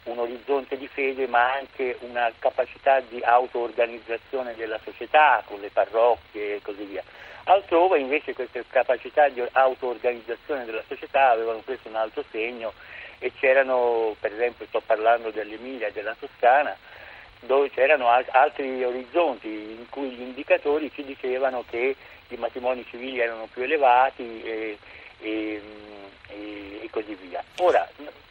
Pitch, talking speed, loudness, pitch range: 125 Hz, 140 wpm, -24 LUFS, 115-135 Hz